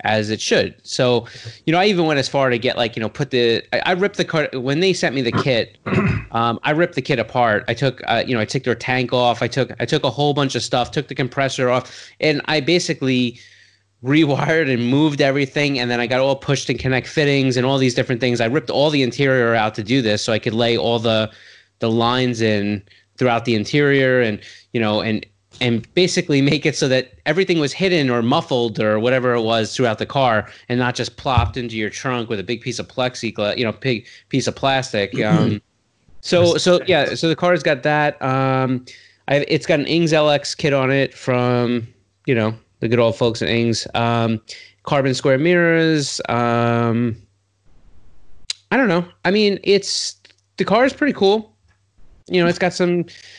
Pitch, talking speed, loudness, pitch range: 125 Hz, 215 wpm, -18 LUFS, 115-145 Hz